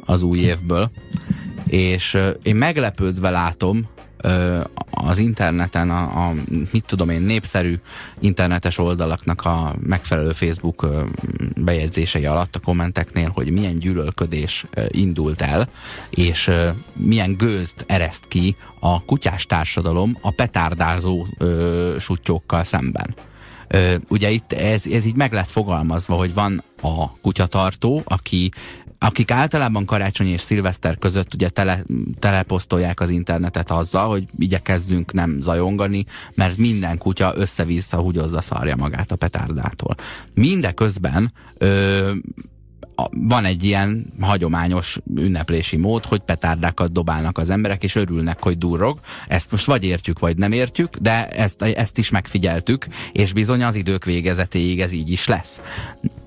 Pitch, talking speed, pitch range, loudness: 90 Hz, 130 wpm, 85-105 Hz, -20 LUFS